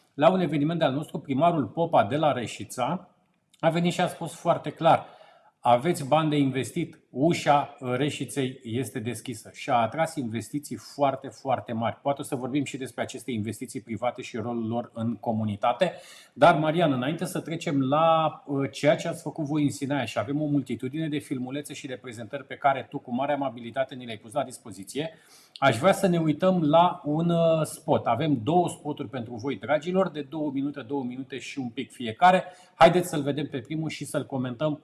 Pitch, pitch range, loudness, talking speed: 145 Hz, 130-160 Hz, -26 LUFS, 190 wpm